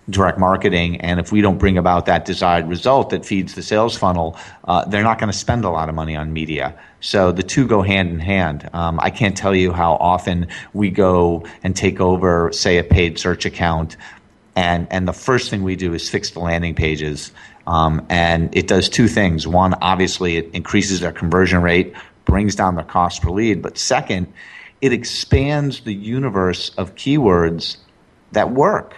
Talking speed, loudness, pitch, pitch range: 195 wpm, -17 LUFS, 90 Hz, 85-100 Hz